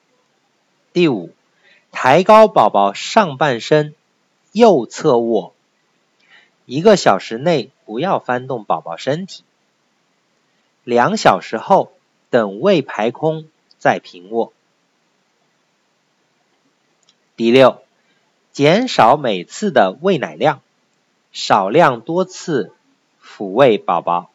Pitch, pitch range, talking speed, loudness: 140 Hz, 115-170 Hz, 135 characters per minute, -15 LUFS